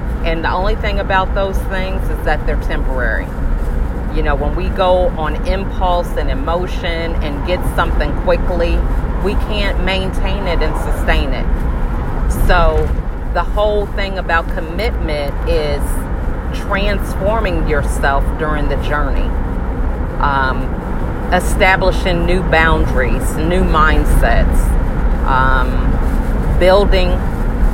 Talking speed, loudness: 110 wpm, -17 LUFS